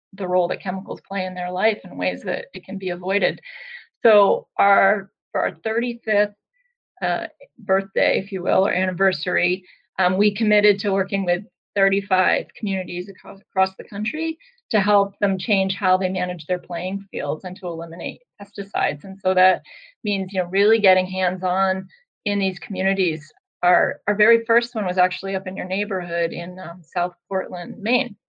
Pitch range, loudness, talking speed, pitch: 185-210 Hz, -21 LUFS, 175 wpm, 190 Hz